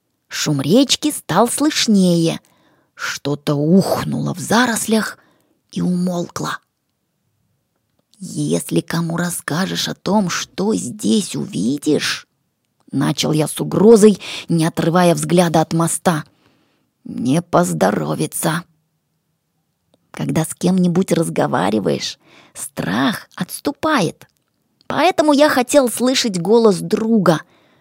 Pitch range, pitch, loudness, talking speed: 160-220 Hz, 180 Hz, -17 LUFS, 90 wpm